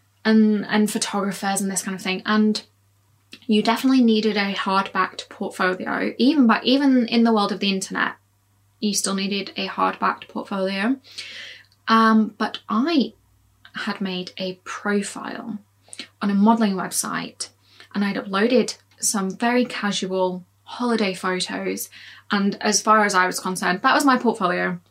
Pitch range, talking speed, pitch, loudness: 185-225 Hz, 150 wpm, 200 Hz, -21 LUFS